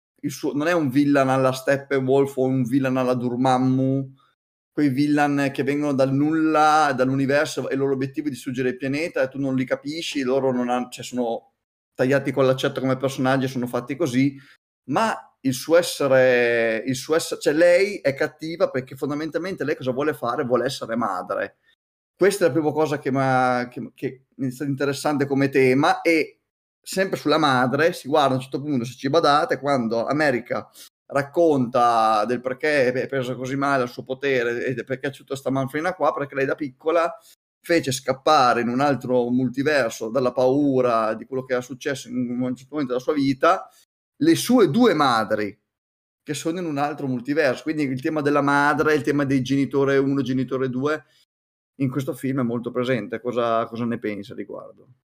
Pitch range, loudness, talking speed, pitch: 130-150 Hz, -22 LUFS, 185 wpm, 135 Hz